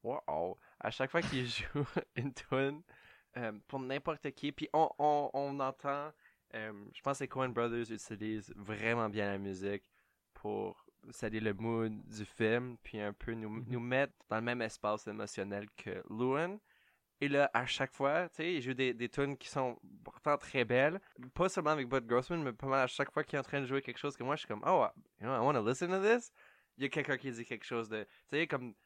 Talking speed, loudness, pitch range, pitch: 230 wpm, -37 LUFS, 110-140 Hz, 130 Hz